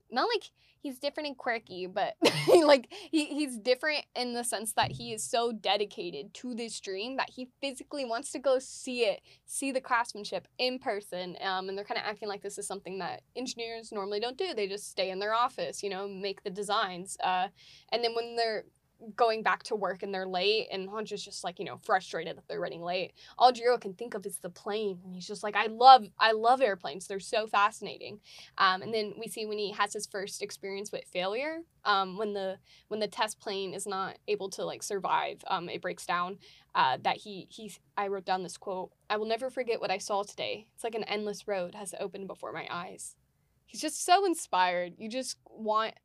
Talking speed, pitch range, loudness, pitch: 220 wpm, 195-240 Hz, -31 LUFS, 210 Hz